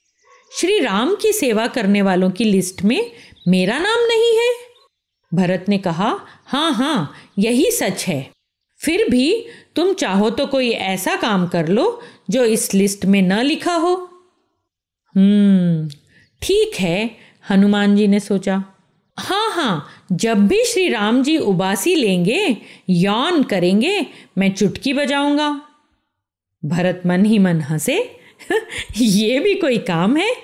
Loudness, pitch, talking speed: -17 LUFS, 220 Hz, 135 wpm